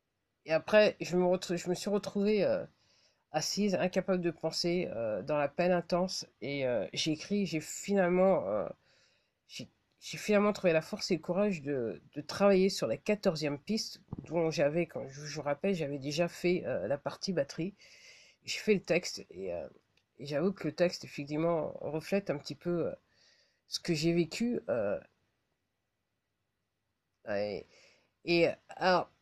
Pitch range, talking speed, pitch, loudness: 145-190 Hz, 165 wpm, 170 Hz, -32 LUFS